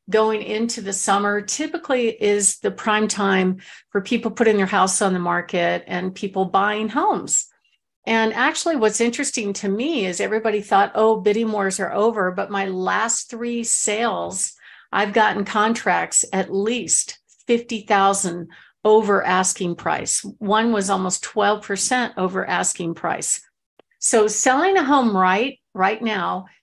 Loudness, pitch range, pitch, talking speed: -20 LUFS, 195-230 Hz, 210 Hz, 145 wpm